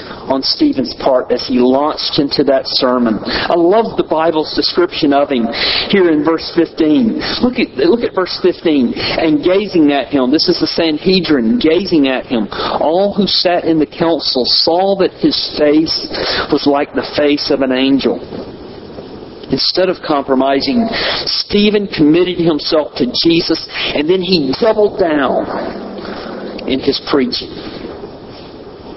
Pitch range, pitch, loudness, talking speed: 145-200 Hz, 165 Hz, -13 LUFS, 145 wpm